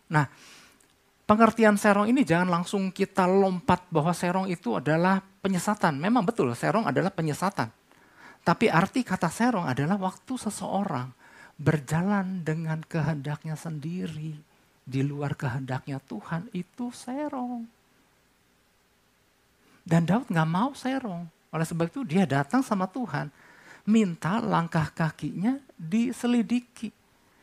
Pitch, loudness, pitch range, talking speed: 185 Hz, -27 LUFS, 160-220 Hz, 110 wpm